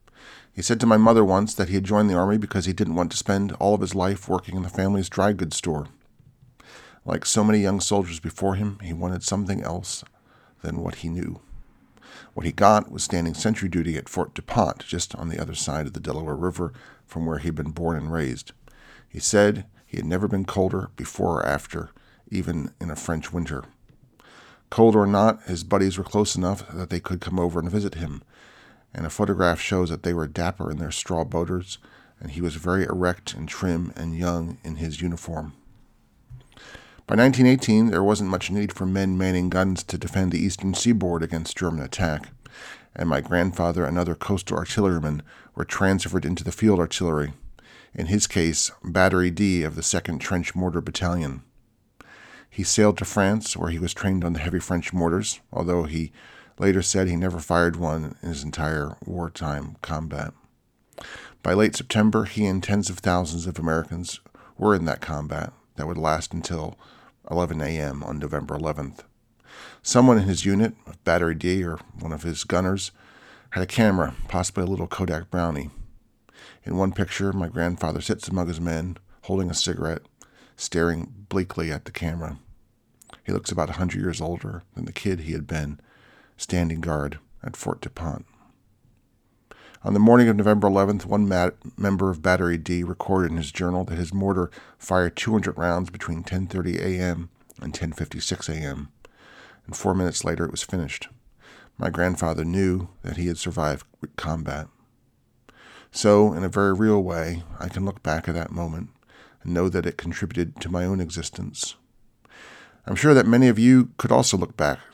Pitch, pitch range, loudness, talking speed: 90 Hz, 85-100 Hz, -24 LUFS, 185 wpm